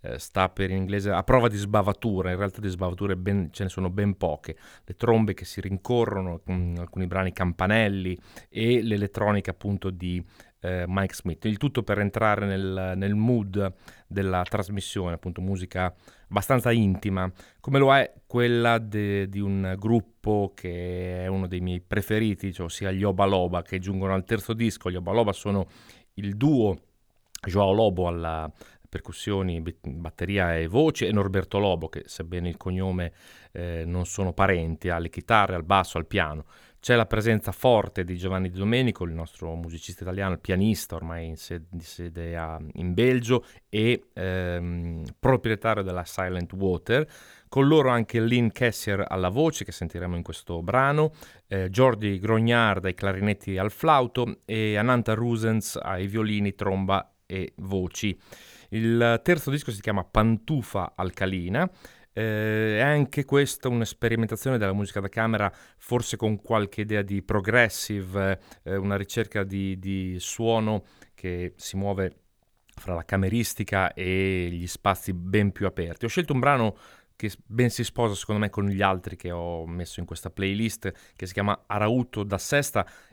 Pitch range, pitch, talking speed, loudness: 90-110 Hz, 100 Hz, 155 wpm, -26 LUFS